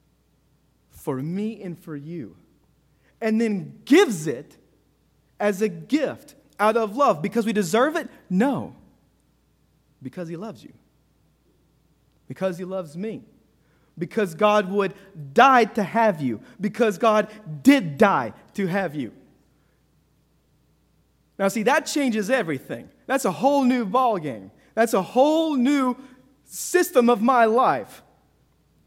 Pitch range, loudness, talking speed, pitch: 180-255 Hz, -22 LUFS, 125 wpm, 215 Hz